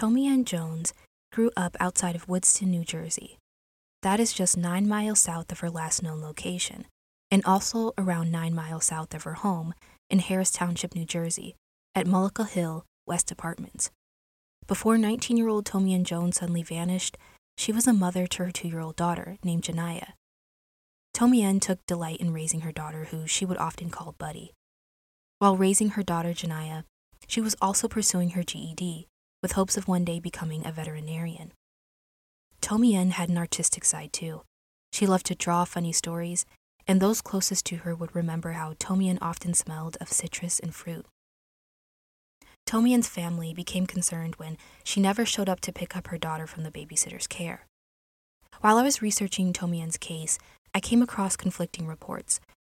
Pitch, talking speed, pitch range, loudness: 175 Hz, 165 wpm, 165-195 Hz, -27 LUFS